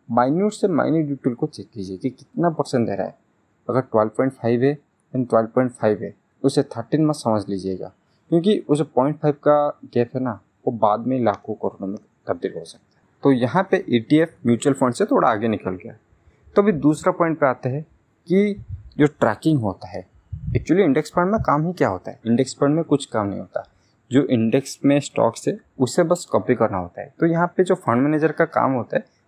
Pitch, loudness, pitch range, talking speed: 135 Hz, -21 LUFS, 115-155 Hz, 225 wpm